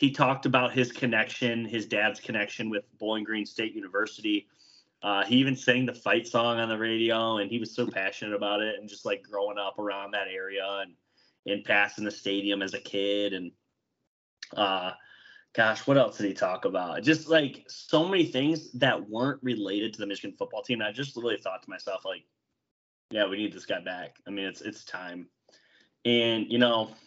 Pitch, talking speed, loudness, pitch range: 110 Hz, 200 wpm, -28 LUFS, 100-125 Hz